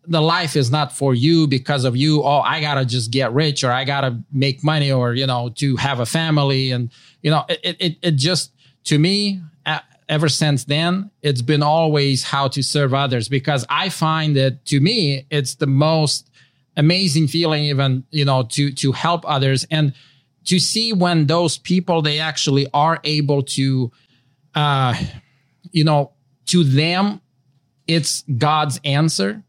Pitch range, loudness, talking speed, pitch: 135-155 Hz, -18 LUFS, 170 wpm, 145 Hz